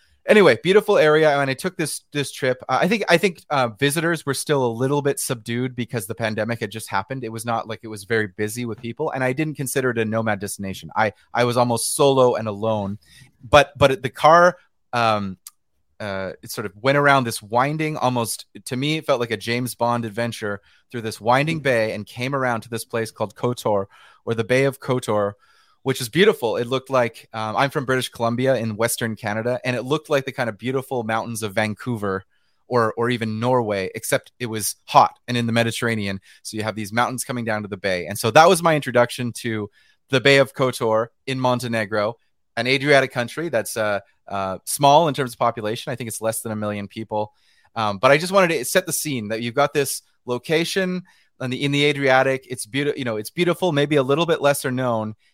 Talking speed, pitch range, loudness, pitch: 220 wpm, 110-140 Hz, -21 LUFS, 120 Hz